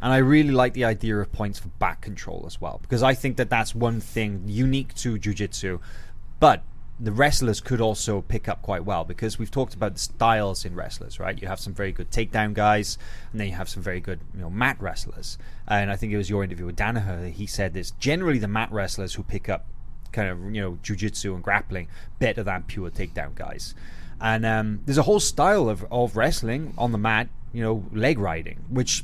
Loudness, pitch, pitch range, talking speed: -25 LUFS, 105 Hz, 95-115 Hz, 220 wpm